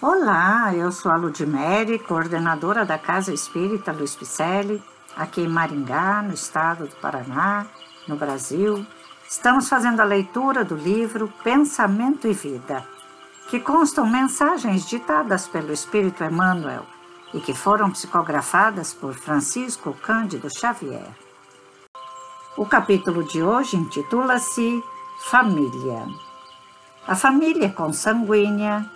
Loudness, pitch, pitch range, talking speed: -21 LUFS, 185 Hz, 150-225 Hz, 110 wpm